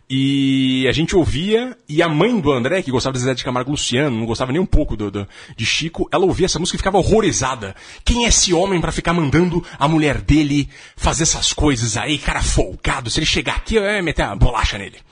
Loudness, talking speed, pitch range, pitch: -17 LUFS, 230 wpm, 130-170 Hz, 150 Hz